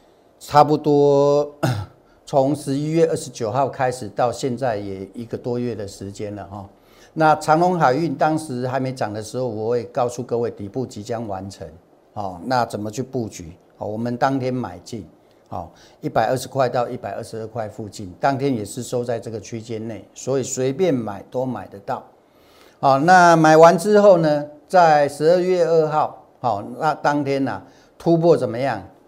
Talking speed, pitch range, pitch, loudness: 255 characters per minute, 110-145 Hz, 125 Hz, -19 LUFS